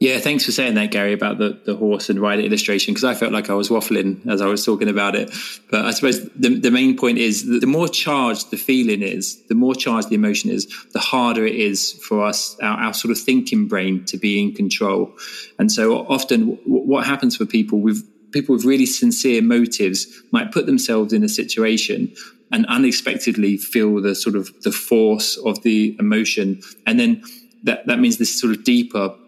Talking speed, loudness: 210 wpm, -18 LUFS